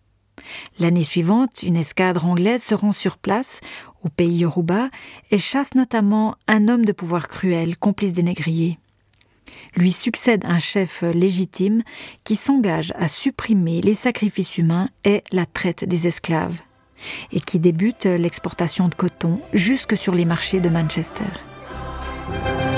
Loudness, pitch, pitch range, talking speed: -20 LUFS, 180 Hz, 170-205 Hz, 135 wpm